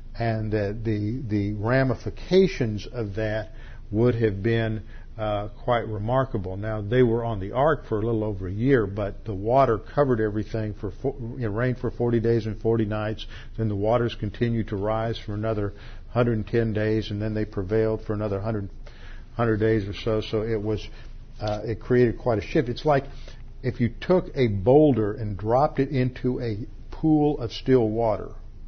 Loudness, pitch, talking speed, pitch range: -25 LUFS, 110 Hz, 180 wpm, 105-120 Hz